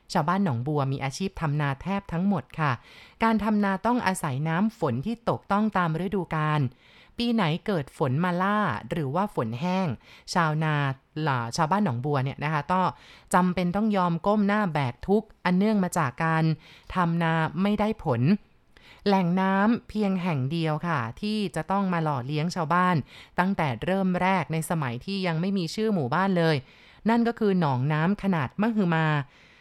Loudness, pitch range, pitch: -26 LUFS, 155-195 Hz, 175 Hz